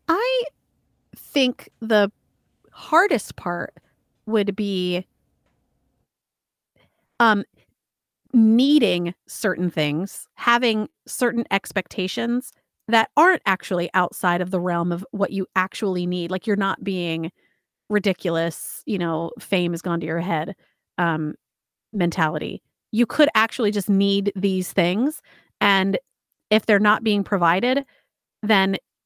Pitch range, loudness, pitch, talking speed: 180-225 Hz, -22 LUFS, 195 Hz, 115 wpm